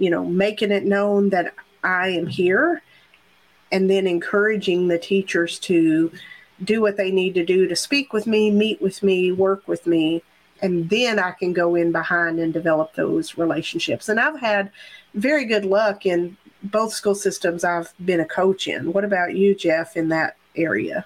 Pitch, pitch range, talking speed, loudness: 190 Hz, 170-205 Hz, 180 wpm, -20 LUFS